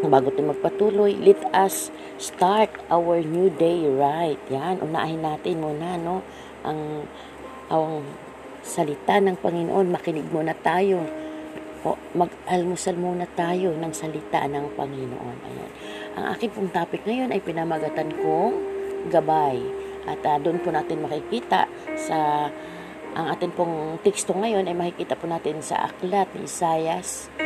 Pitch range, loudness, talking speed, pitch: 155-195 Hz, -24 LUFS, 135 wpm, 170 Hz